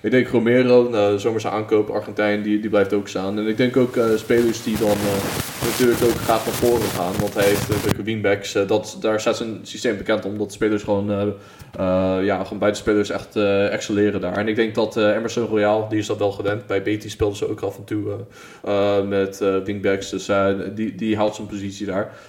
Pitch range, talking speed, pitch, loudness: 100-110 Hz, 235 wpm, 105 Hz, -21 LUFS